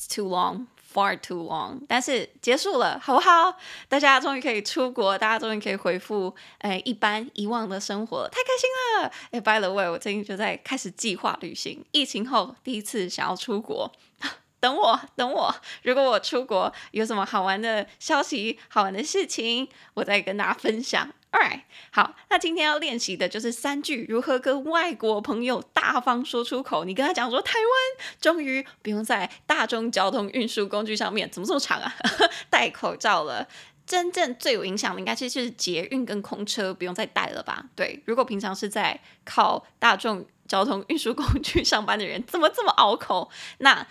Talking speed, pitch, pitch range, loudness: 315 characters per minute, 230 Hz, 205-275 Hz, -25 LUFS